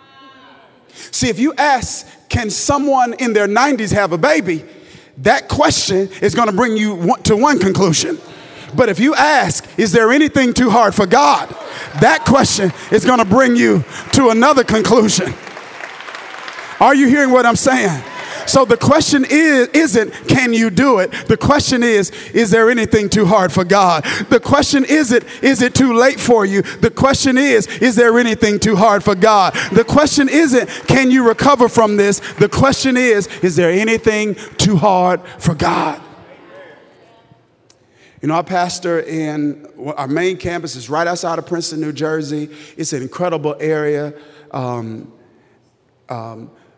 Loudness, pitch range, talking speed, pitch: -13 LUFS, 180-255 Hz, 160 wpm, 220 Hz